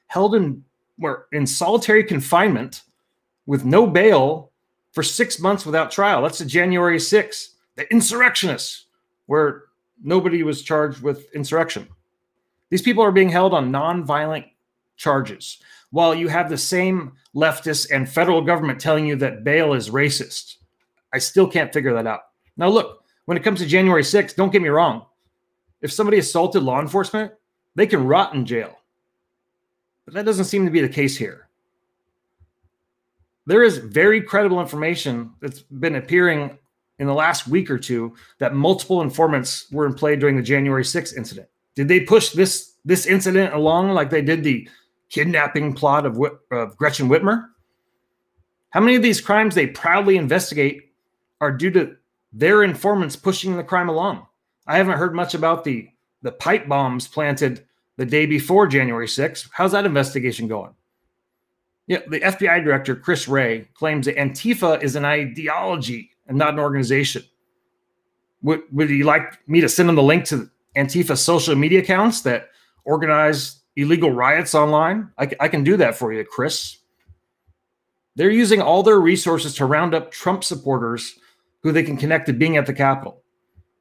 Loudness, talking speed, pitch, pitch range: -18 LUFS, 165 wpm, 155 Hz, 140-180 Hz